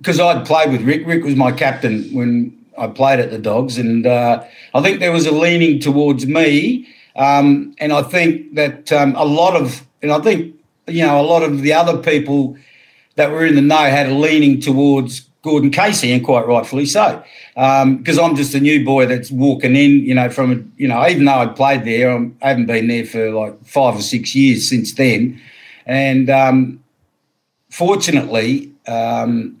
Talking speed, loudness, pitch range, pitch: 195 wpm, -14 LUFS, 125-150 Hz, 140 Hz